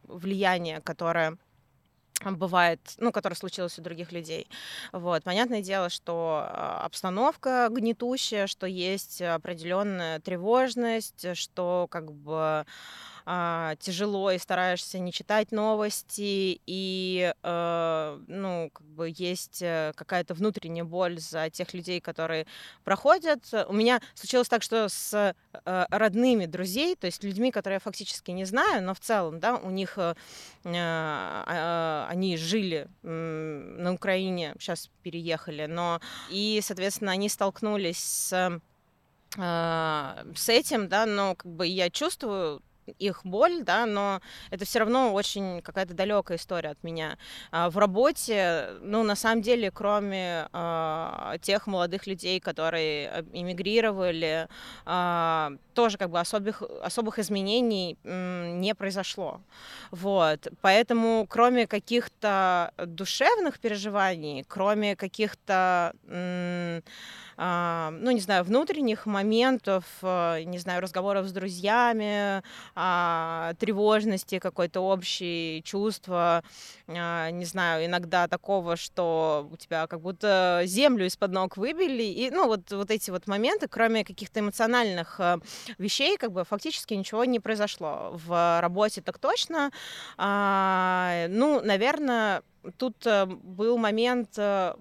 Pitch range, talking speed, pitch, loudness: 170-215 Hz, 115 wpm, 190 Hz, -28 LUFS